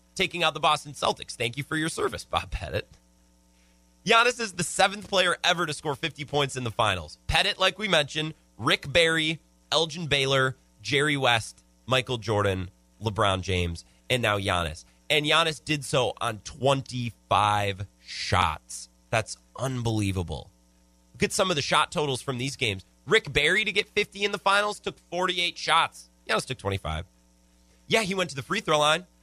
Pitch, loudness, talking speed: 130 Hz, -25 LUFS, 170 wpm